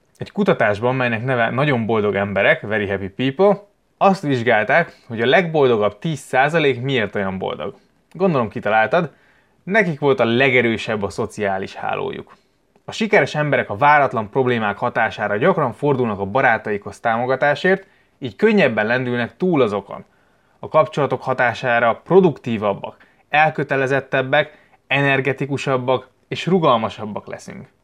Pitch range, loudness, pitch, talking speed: 115-150 Hz, -18 LUFS, 130 Hz, 115 wpm